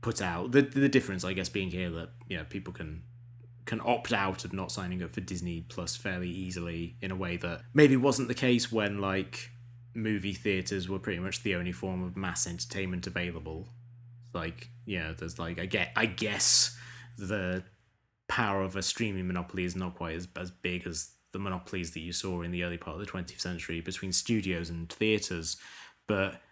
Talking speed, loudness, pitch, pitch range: 200 wpm, -31 LUFS, 95 Hz, 90-115 Hz